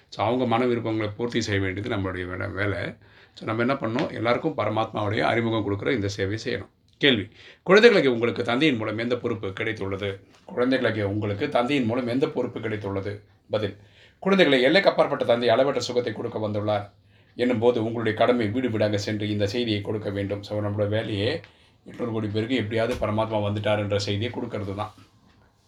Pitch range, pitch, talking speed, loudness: 100-120 Hz, 110 Hz, 160 wpm, -24 LUFS